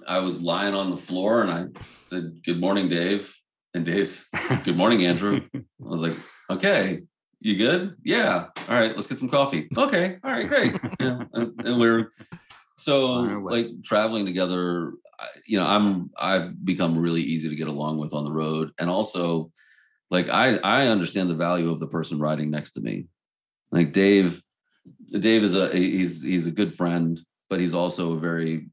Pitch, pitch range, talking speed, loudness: 90 Hz, 85-105 Hz, 180 wpm, -24 LUFS